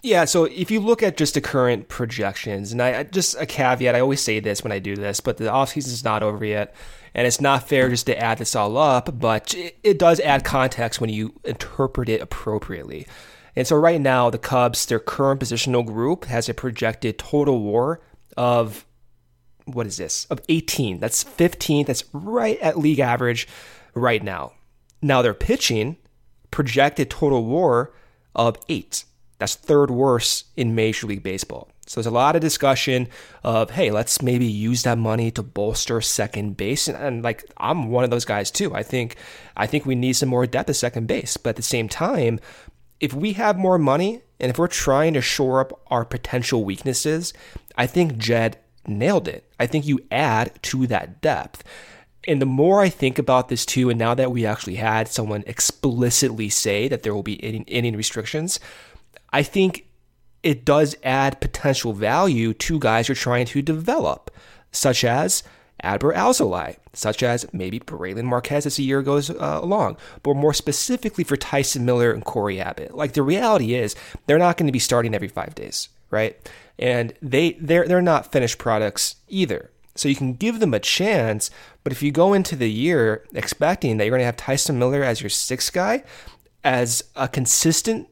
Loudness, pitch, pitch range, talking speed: -21 LUFS, 125 Hz, 115-145 Hz, 190 wpm